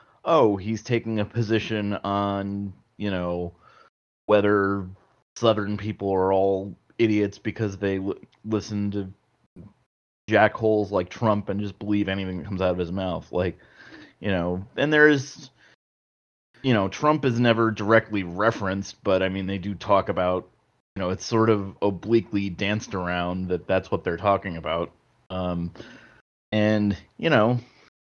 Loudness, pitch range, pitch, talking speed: -24 LUFS, 95-110 Hz, 100 Hz, 150 wpm